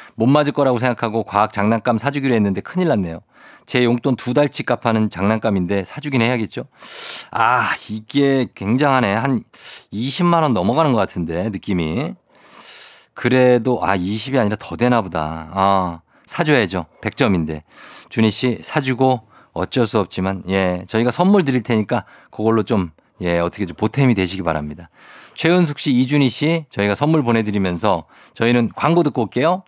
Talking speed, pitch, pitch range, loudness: 325 characters per minute, 115 Hz, 95-130 Hz, -18 LUFS